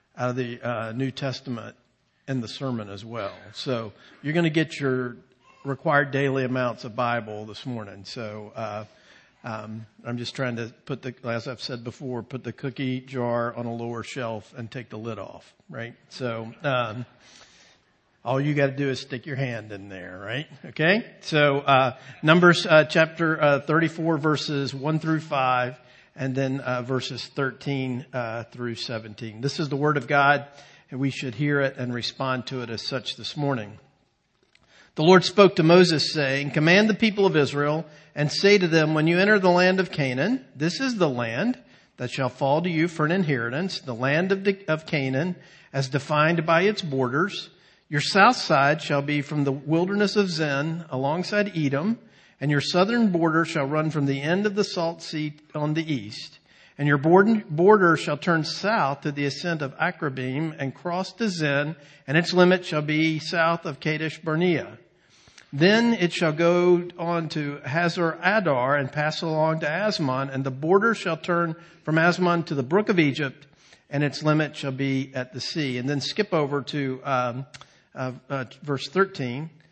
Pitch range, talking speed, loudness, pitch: 130-165 Hz, 180 wpm, -24 LUFS, 145 Hz